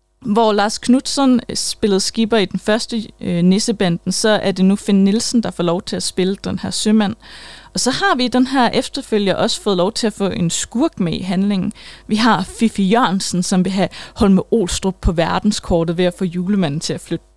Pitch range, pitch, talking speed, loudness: 185-225 Hz, 205 Hz, 215 wpm, -17 LUFS